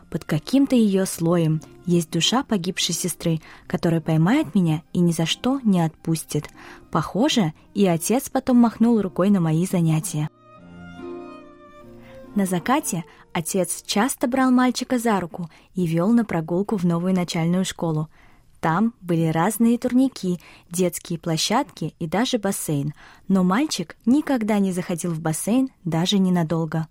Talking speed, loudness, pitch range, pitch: 135 wpm, -22 LUFS, 165-230 Hz, 180 Hz